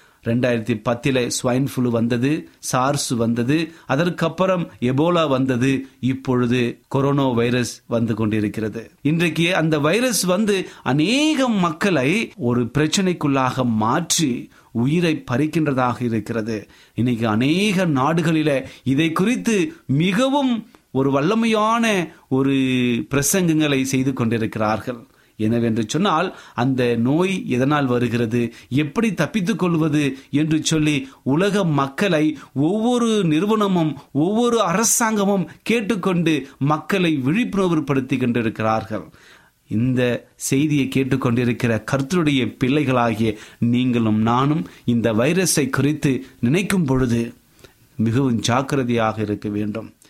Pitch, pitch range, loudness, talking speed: 135 Hz, 120-165 Hz, -20 LUFS, 90 wpm